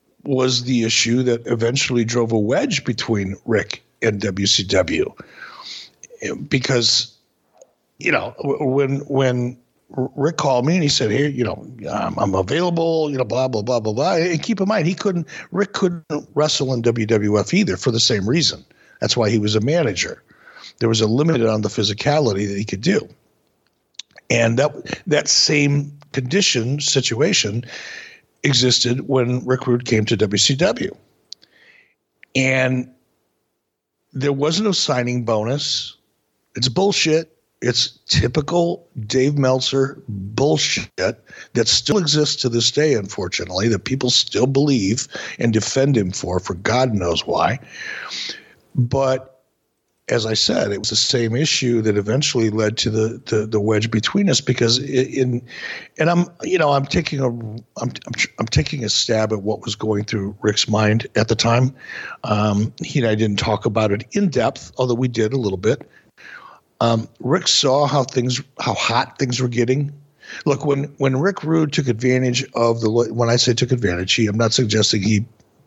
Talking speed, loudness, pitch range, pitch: 160 wpm, -19 LUFS, 110-145 Hz, 125 Hz